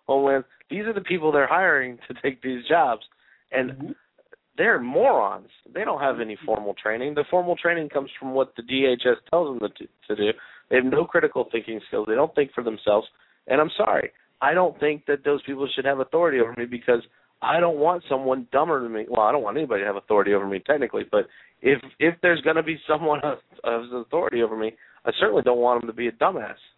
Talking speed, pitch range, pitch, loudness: 220 wpm, 120-165 Hz, 140 Hz, -23 LUFS